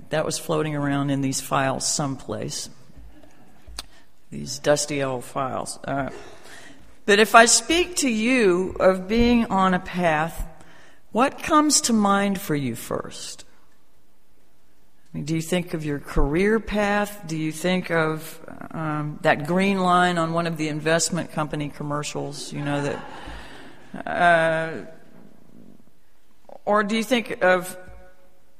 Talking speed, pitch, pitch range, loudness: 135 wpm, 165 Hz, 145-200 Hz, -22 LUFS